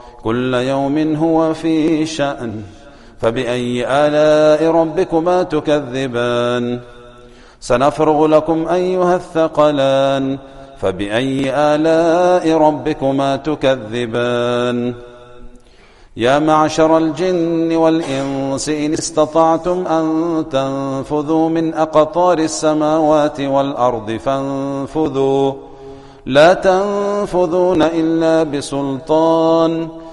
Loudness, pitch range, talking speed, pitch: -15 LUFS, 135-160 Hz, 70 wpm, 150 Hz